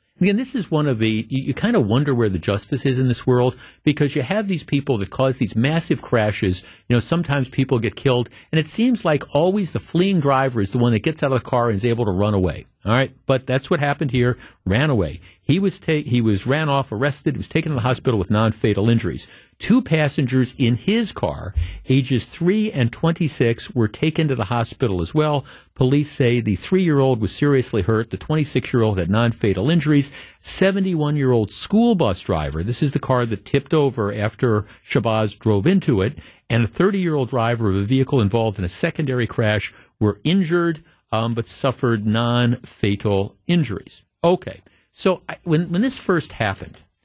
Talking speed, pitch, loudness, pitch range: 200 wpm, 130 Hz, -20 LUFS, 110-155 Hz